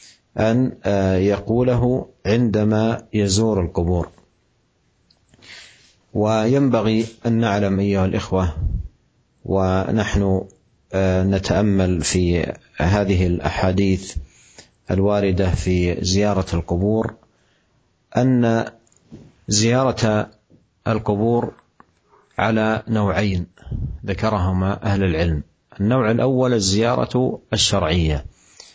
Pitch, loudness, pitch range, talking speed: 100 Hz, -20 LUFS, 95-110 Hz, 65 wpm